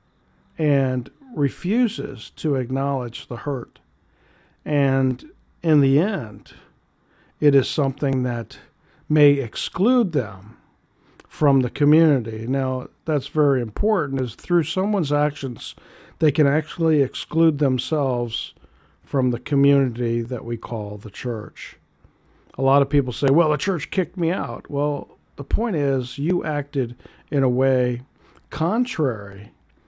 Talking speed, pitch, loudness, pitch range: 125 wpm, 140 Hz, -22 LUFS, 125-150 Hz